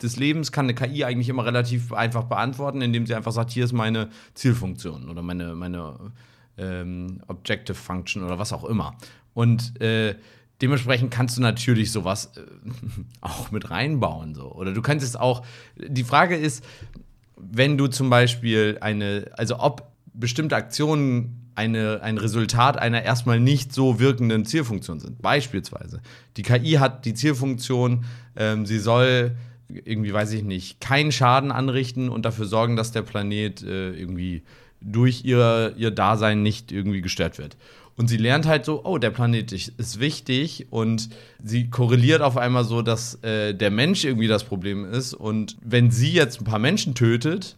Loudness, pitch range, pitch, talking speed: -23 LUFS, 110-125 Hz, 120 Hz, 165 wpm